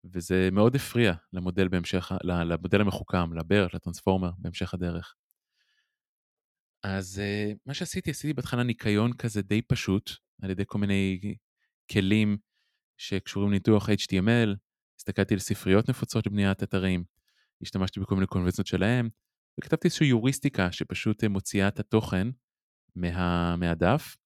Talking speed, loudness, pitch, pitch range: 115 wpm, -28 LUFS, 100 Hz, 95-110 Hz